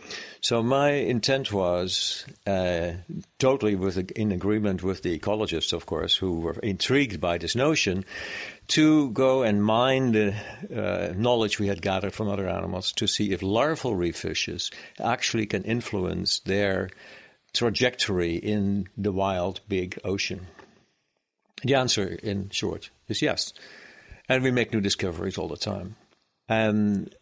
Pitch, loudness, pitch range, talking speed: 100 Hz, -26 LUFS, 95-115 Hz, 145 wpm